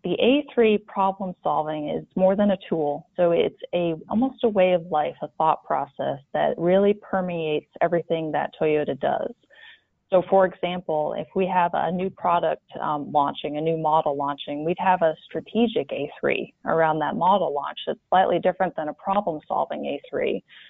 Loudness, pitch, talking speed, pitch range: -24 LUFS, 175 Hz, 170 wpm, 155-190 Hz